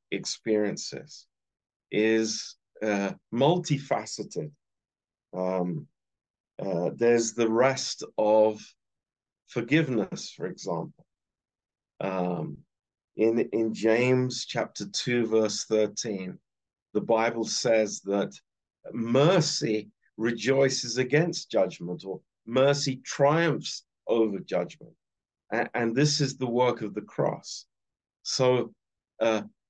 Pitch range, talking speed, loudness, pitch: 105-130 Hz, 90 wpm, -27 LUFS, 115 Hz